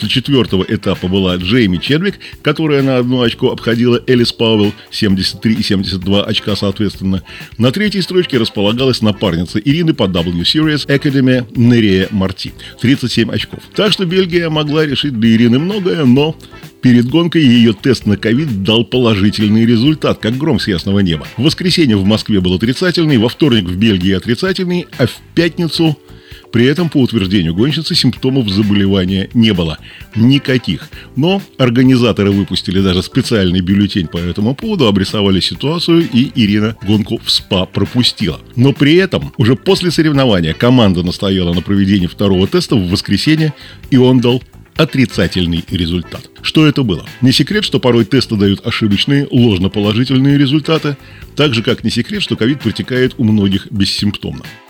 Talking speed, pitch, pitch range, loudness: 150 wpm, 115 Hz, 100-140 Hz, -13 LUFS